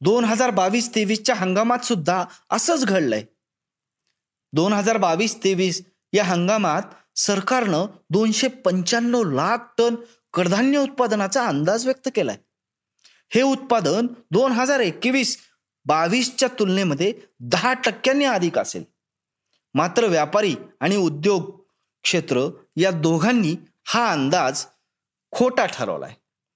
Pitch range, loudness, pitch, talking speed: 185-245 Hz, -21 LUFS, 215 Hz, 105 wpm